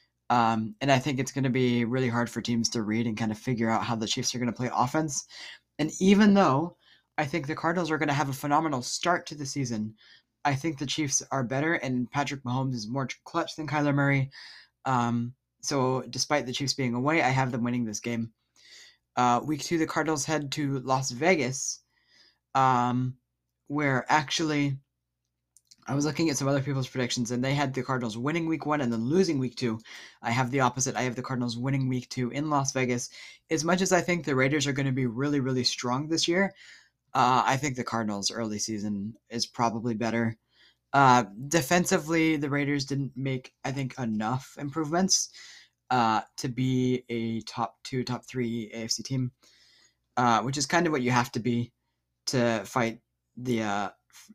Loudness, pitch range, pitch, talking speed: -28 LUFS, 120-145 Hz, 130 Hz, 200 wpm